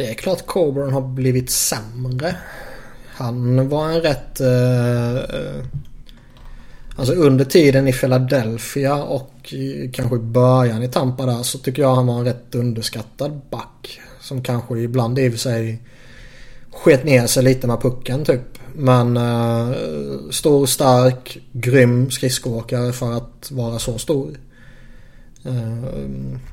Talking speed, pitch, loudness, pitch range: 135 wpm, 130 Hz, -18 LUFS, 120-135 Hz